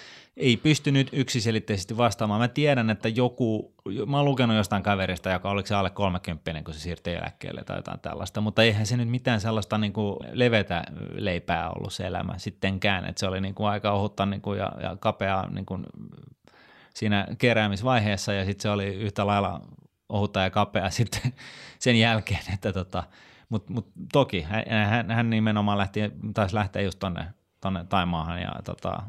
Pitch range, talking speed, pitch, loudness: 95-115 Hz, 165 wpm, 105 Hz, -26 LUFS